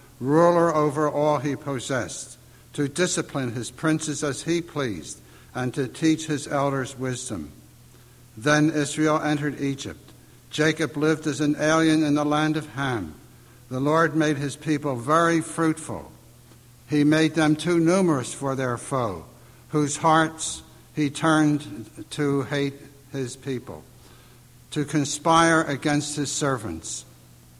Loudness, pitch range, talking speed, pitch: -24 LUFS, 130-155 Hz, 130 wpm, 145 Hz